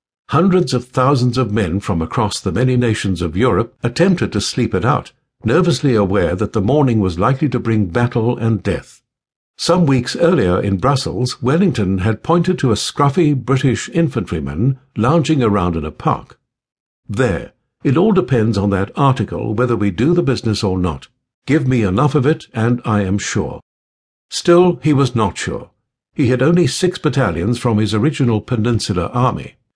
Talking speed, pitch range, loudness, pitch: 170 wpm, 105-140 Hz, -16 LUFS, 120 Hz